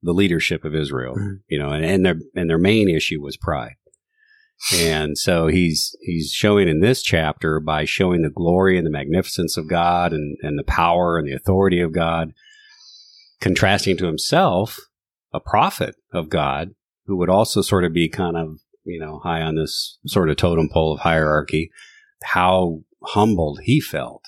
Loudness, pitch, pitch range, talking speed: -19 LUFS, 85 Hz, 80-95 Hz, 175 wpm